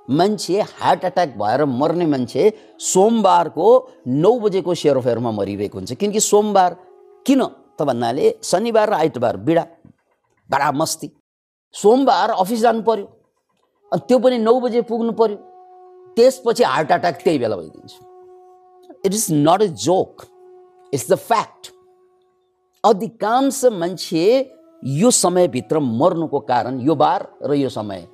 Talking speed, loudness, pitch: 125 wpm, -18 LUFS, 215 Hz